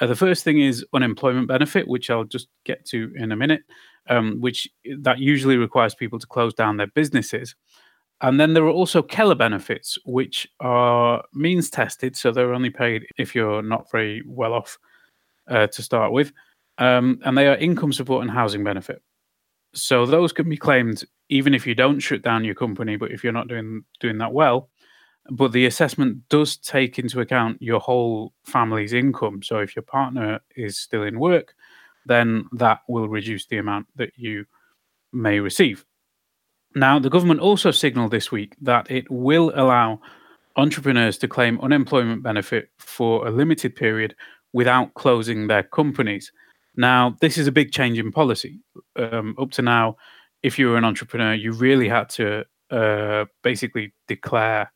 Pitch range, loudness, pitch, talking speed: 115-135 Hz, -20 LUFS, 125 Hz, 175 wpm